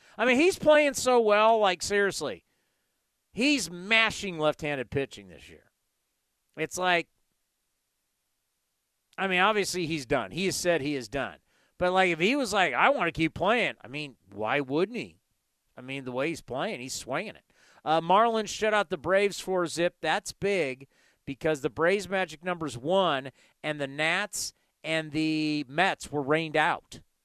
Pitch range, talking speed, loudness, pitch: 145-195 Hz, 175 wpm, -27 LUFS, 165 Hz